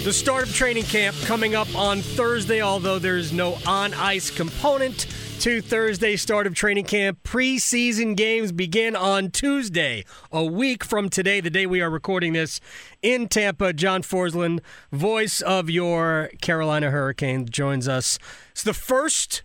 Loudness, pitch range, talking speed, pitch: -22 LUFS, 170-225 Hz, 155 wpm, 195 Hz